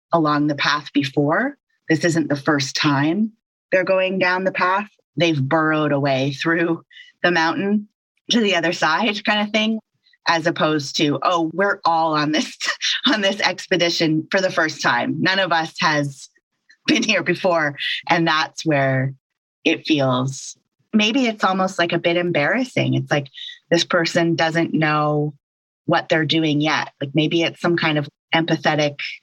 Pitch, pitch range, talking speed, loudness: 165 Hz, 150-190 Hz, 160 wpm, -19 LUFS